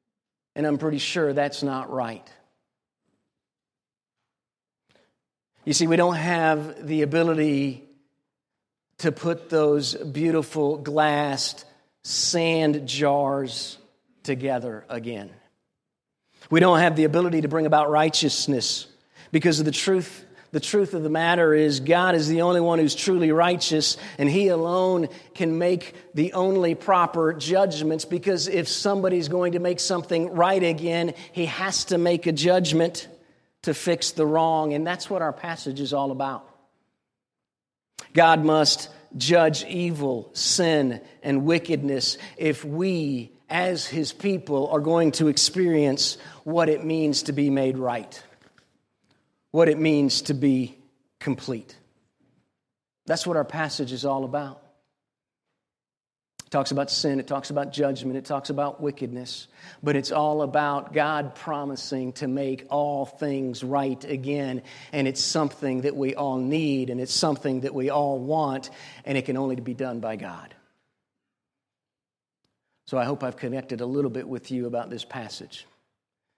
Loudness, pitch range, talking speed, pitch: -24 LUFS, 140-165 Hz, 140 wpm, 150 Hz